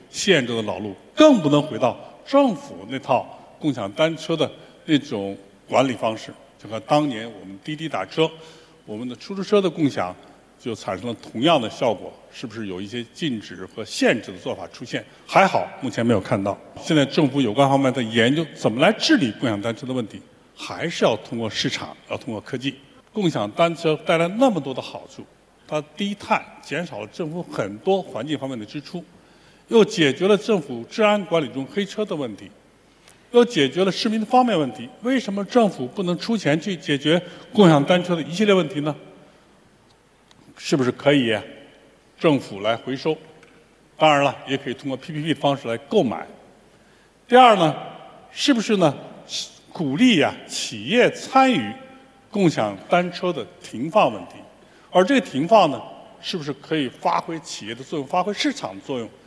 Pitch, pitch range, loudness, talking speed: 160 Hz, 135-200 Hz, -21 LUFS, 270 characters per minute